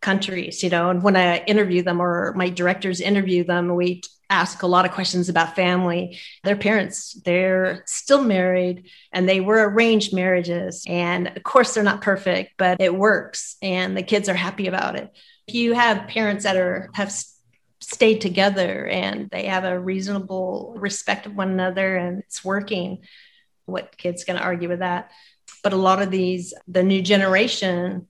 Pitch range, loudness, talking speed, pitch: 180-200 Hz, -21 LUFS, 175 wpm, 185 Hz